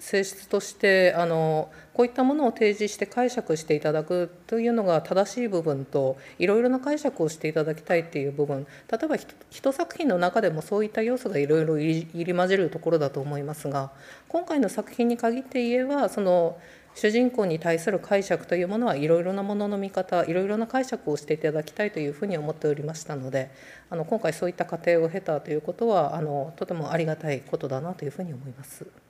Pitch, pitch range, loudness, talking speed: 175 Hz, 155-215 Hz, -26 LUFS, 435 characters per minute